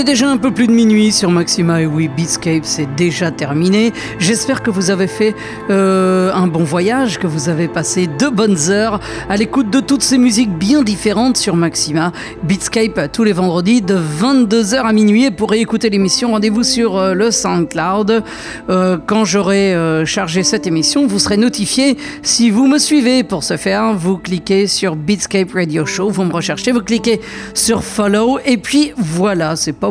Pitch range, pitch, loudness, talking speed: 180-230 Hz, 205 Hz, -13 LUFS, 185 wpm